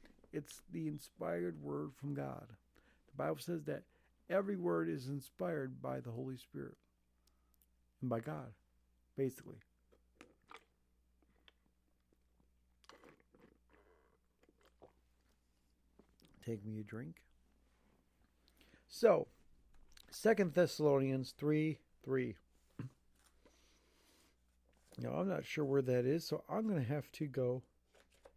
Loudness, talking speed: -40 LUFS, 95 wpm